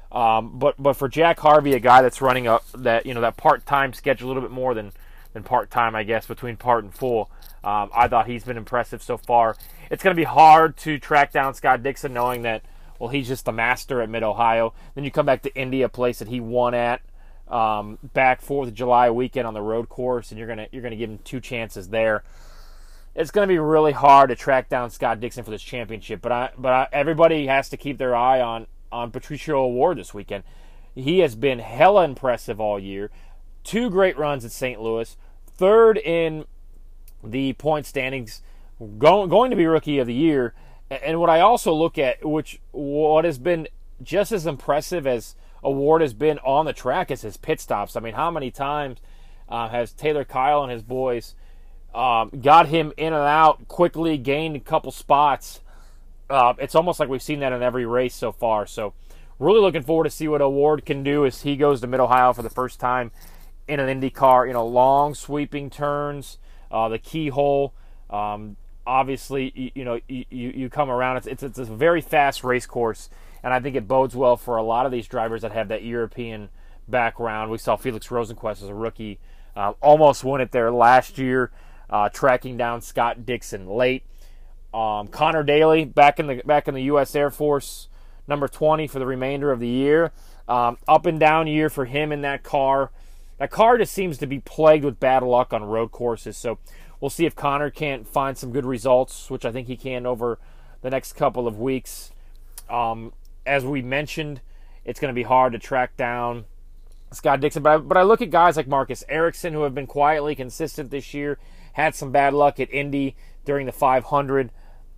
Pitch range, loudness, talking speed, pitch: 115-145 Hz, -21 LUFS, 205 wpm, 130 Hz